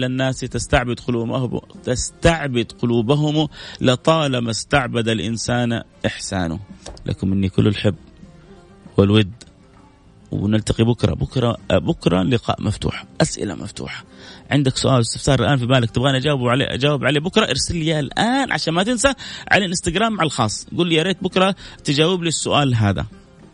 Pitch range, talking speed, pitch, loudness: 110-160 Hz, 140 wpm, 130 Hz, -19 LUFS